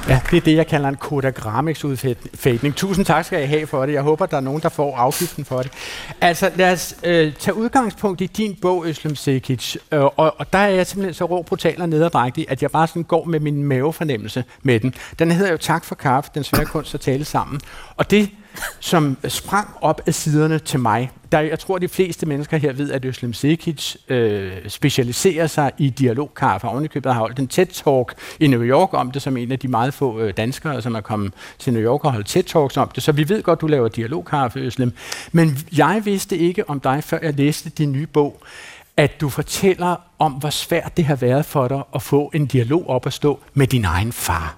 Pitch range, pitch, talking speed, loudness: 130-165 Hz, 150 Hz, 225 wpm, -19 LUFS